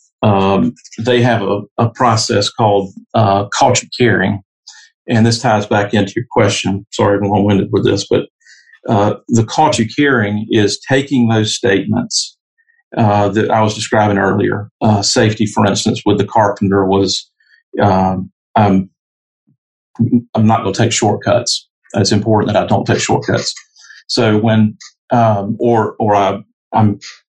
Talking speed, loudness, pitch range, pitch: 150 wpm, -14 LUFS, 100-115 Hz, 105 Hz